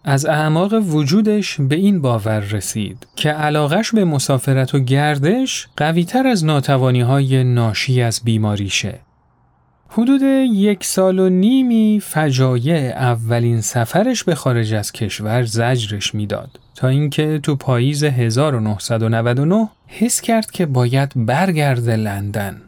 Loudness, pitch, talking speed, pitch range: -16 LUFS, 140 Hz, 120 wpm, 120-185 Hz